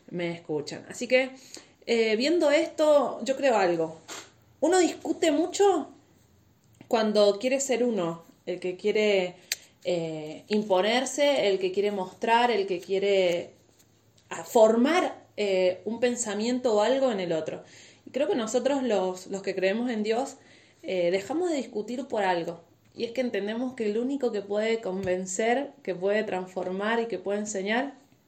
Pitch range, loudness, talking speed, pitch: 185-255 Hz, -27 LUFS, 150 wpm, 210 Hz